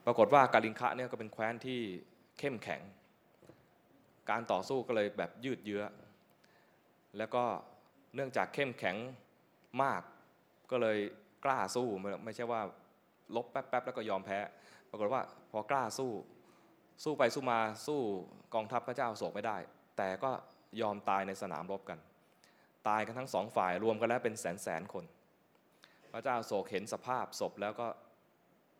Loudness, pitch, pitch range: -37 LUFS, 110 Hz, 100-125 Hz